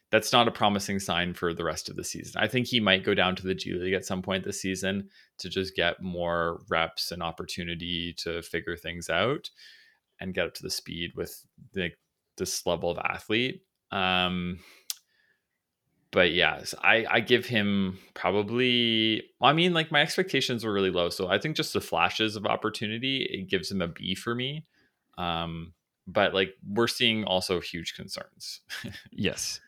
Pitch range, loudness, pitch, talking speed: 90-115 Hz, -27 LUFS, 95 Hz, 185 wpm